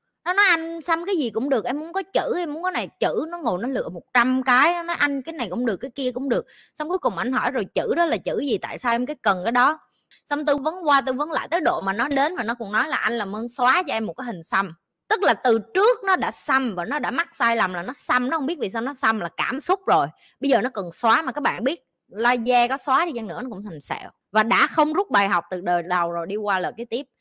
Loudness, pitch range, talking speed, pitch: -22 LUFS, 225-310 Hz, 310 wpm, 255 Hz